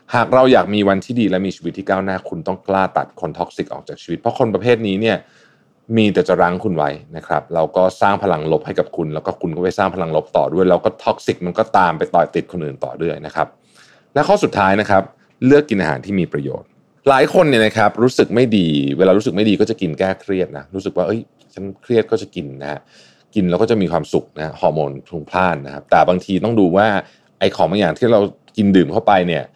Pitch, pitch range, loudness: 95 Hz, 90-110 Hz, -17 LUFS